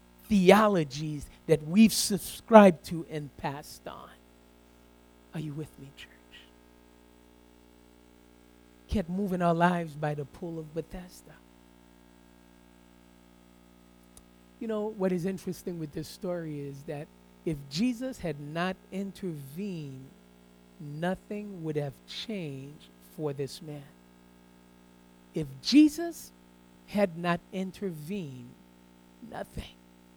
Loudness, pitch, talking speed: -29 LUFS, 140 Hz, 100 wpm